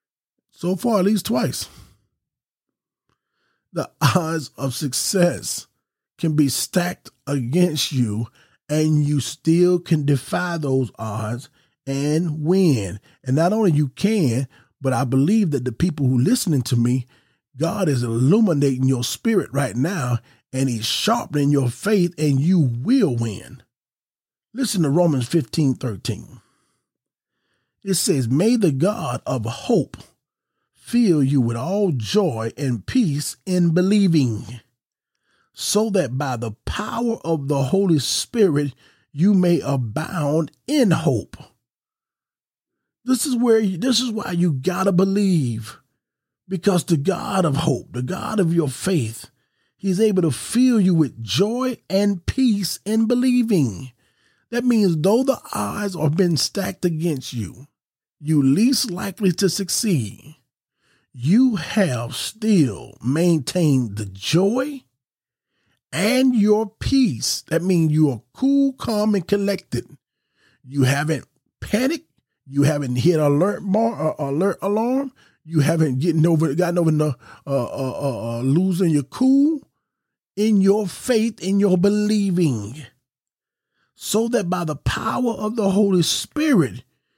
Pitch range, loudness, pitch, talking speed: 135-200 Hz, -20 LUFS, 165 Hz, 130 wpm